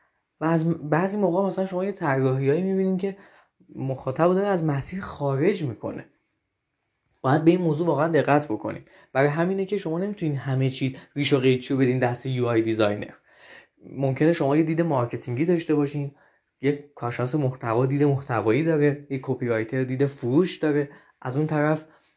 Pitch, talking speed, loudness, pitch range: 145 Hz, 160 wpm, -24 LUFS, 130-165 Hz